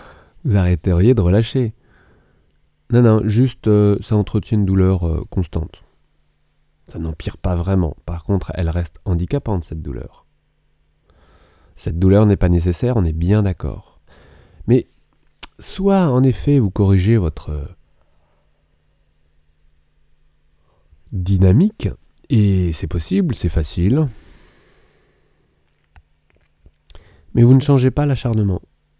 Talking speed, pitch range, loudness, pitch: 110 wpm, 75-105 Hz, -17 LUFS, 90 Hz